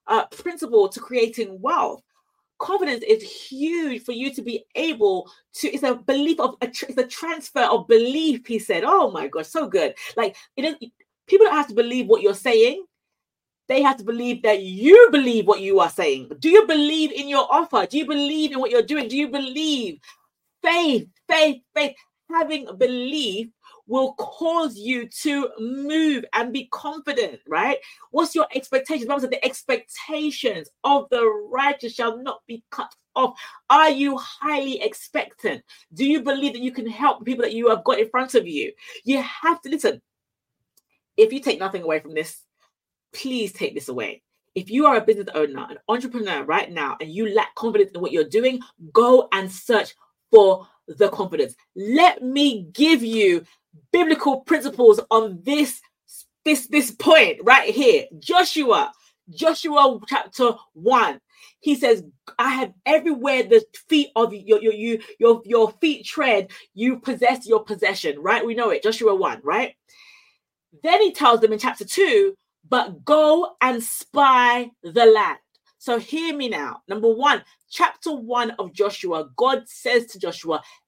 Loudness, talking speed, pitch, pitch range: -20 LUFS, 165 wpm, 275 Hz, 230-320 Hz